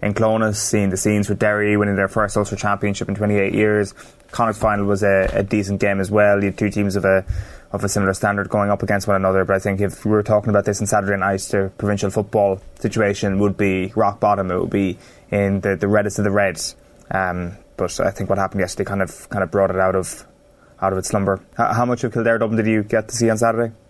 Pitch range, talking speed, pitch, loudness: 95-105 Hz, 250 wpm, 100 Hz, -19 LUFS